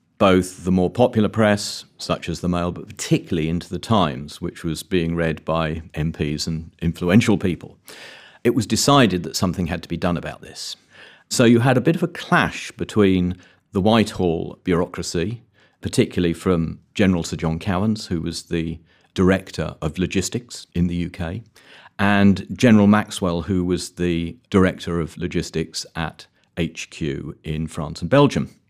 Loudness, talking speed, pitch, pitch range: -21 LUFS, 160 wpm, 90 Hz, 85-105 Hz